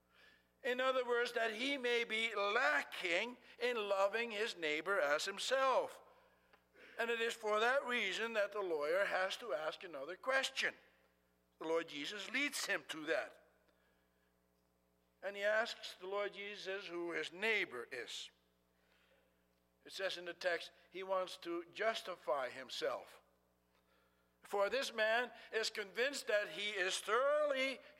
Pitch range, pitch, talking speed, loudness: 155-235 Hz, 200 Hz, 135 wpm, -39 LUFS